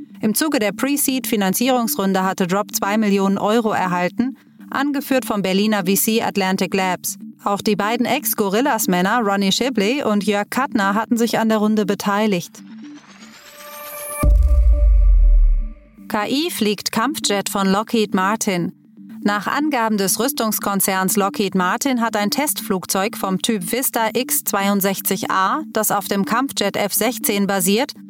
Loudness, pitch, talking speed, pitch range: -19 LUFS, 215 Hz, 120 wpm, 195-240 Hz